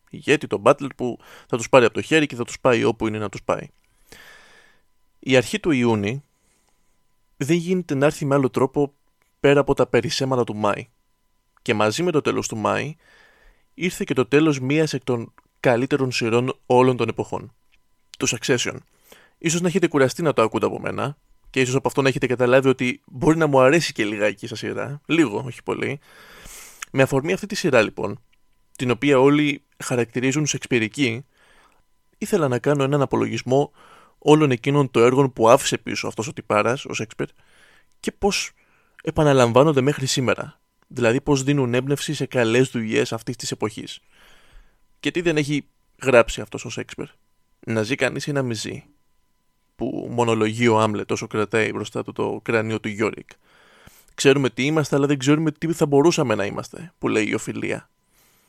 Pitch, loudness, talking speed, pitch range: 135 Hz, -21 LUFS, 175 wpm, 120-145 Hz